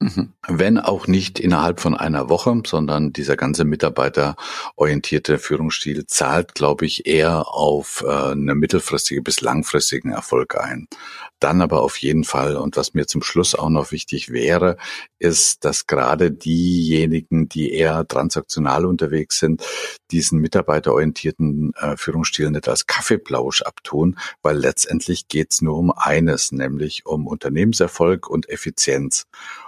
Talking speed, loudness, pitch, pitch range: 135 wpm, -19 LUFS, 80 Hz, 75-85 Hz